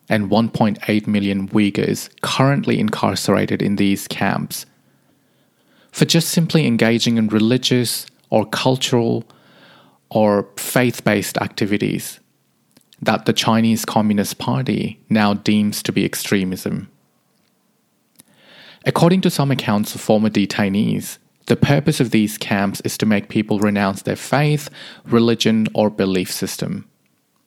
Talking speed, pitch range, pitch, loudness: 120 wpm, 105-125 Hz, 110 Hz, -18 LUFS